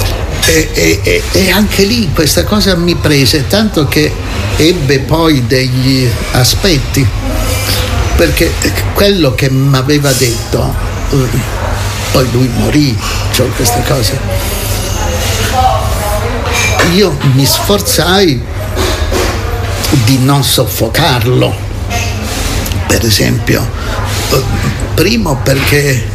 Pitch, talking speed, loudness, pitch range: 105 Hz, 85 wpm, -10 LUFS, 100-130 Hz